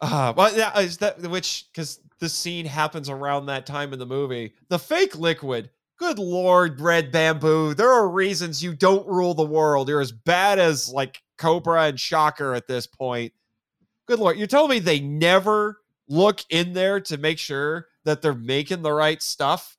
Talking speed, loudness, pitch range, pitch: 185 wpm, -22 LUFS, 145-185 Hz, 160 Hz